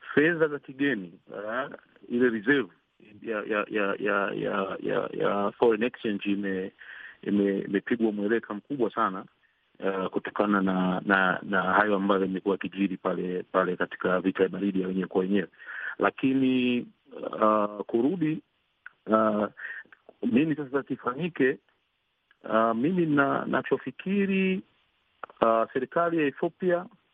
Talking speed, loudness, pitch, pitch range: 120 wpm, -27 LUFS, 105 Hz, 95-140 Hz